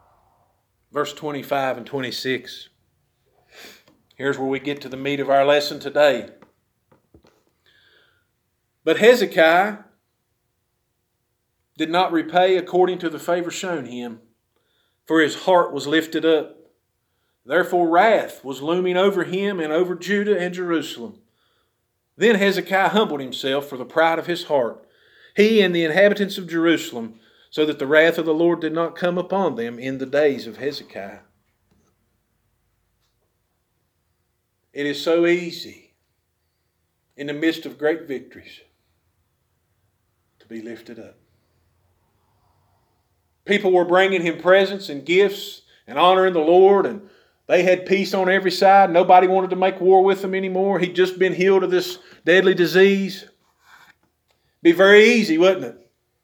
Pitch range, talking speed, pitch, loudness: 120-185 Hz, 140 wpm, 160 Hz, -19 LUFS